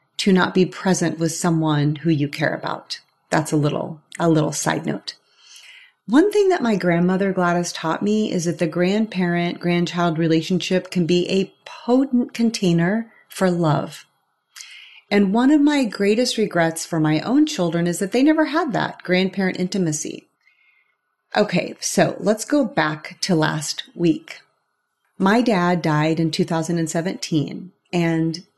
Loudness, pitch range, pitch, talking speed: -20 LUFS, 165-215 Hz, 180 Hz, 145 wpm